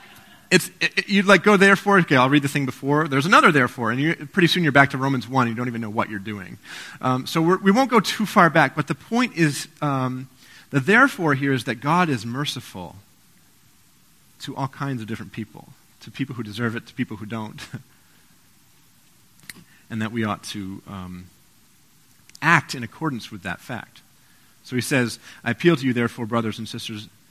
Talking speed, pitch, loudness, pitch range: 200 wpm, 130 Hz, -20 LUFS, 115-155 Hz